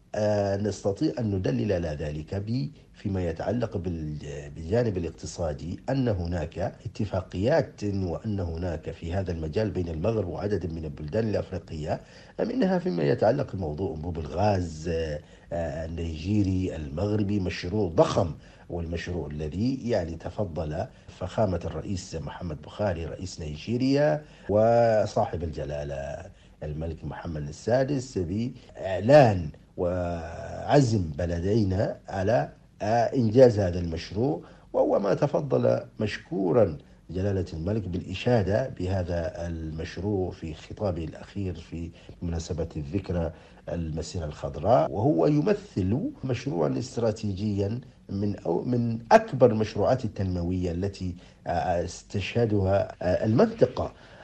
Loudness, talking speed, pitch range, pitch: -27 LUFS, 95 wpm, 85-110 Hz, 95 Hz